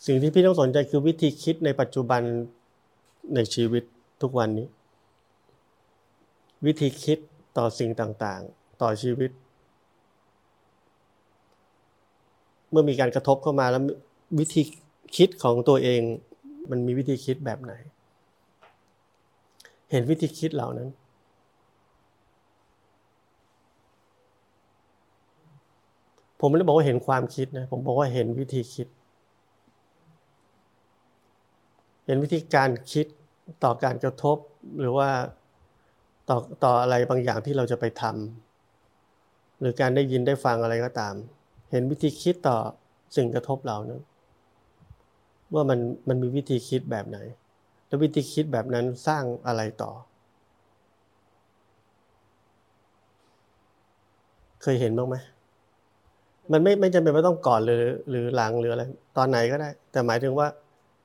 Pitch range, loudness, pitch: 115-145 Hz, -25 LUFS, 125 Hz